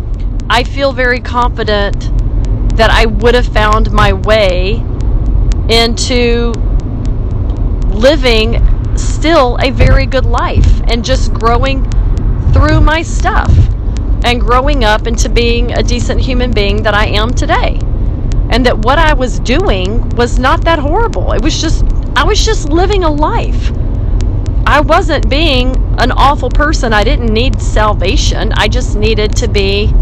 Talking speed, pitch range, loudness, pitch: 140 wpm, 100-115 Hz, -11 LUFS, 105 Hz